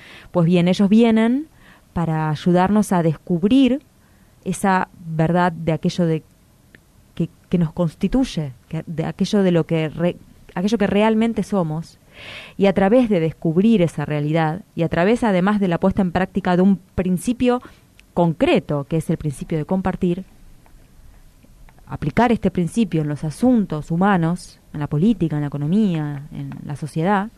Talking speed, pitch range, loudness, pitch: 150 wpm, 160-200 Hz, -19 LUFS, 175 Hz